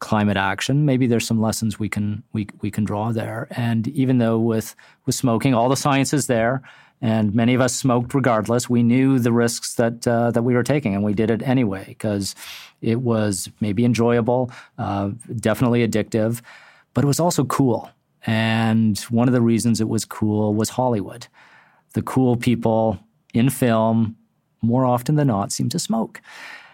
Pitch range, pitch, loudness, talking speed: 110-125 Hz, 115 Hz, -20 LUFS, 180 wpm